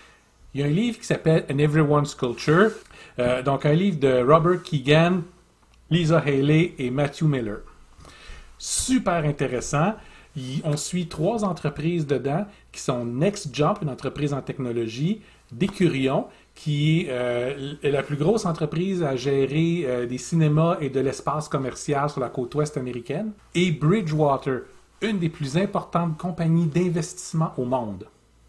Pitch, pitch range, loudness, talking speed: 150 Hz, 135-175 Hz, -24 LUFS, 145 wpm